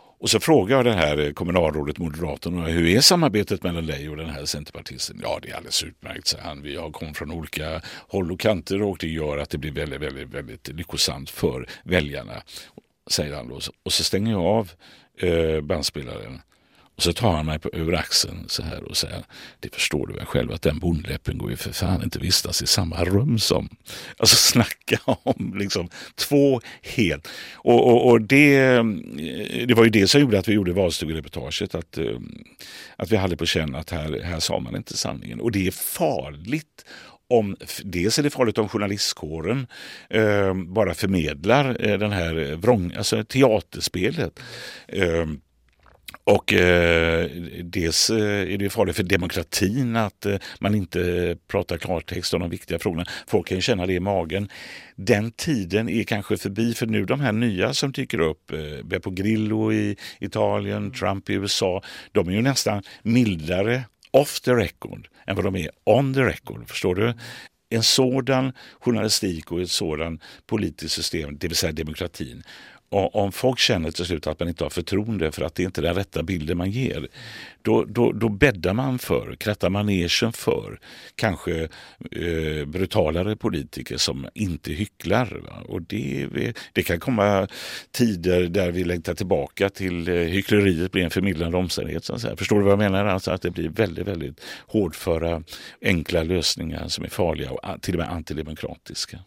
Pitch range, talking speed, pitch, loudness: 85-105 Hz, 175 wpm, 95 Hz, -23 LUFS